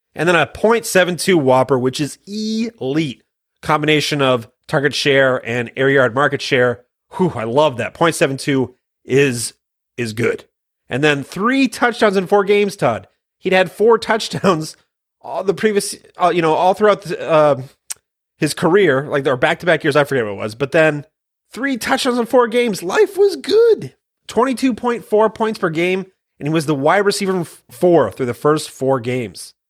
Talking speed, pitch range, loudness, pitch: 170 wpm, 135-210 Hz, -16 LUFS, 165 Hz